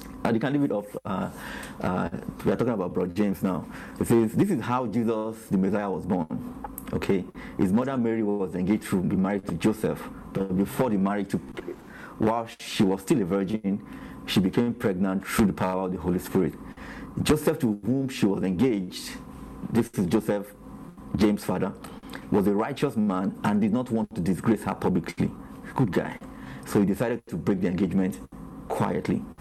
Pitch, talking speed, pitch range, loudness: 110 Hz, 180 wpm, 95-120 Hz, -27 LUFS